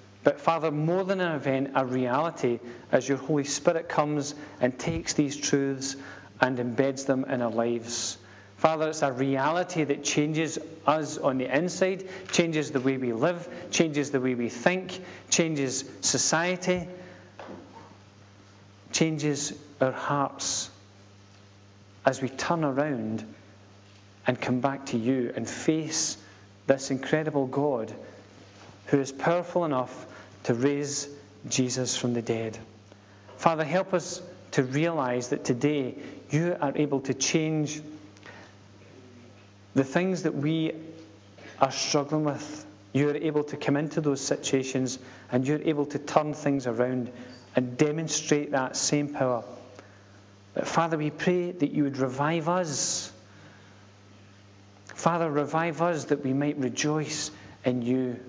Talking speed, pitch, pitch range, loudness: 135 wpm, 135 Hz, 115-155 Hz, -28 LUFS